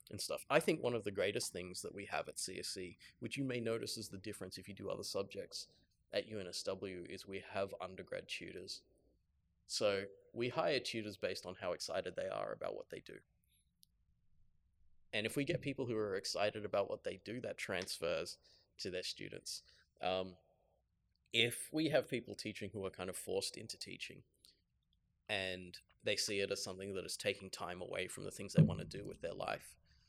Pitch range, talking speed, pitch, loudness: 95-140 Hz, 195 wpm, 105 Hz, -41 LUFS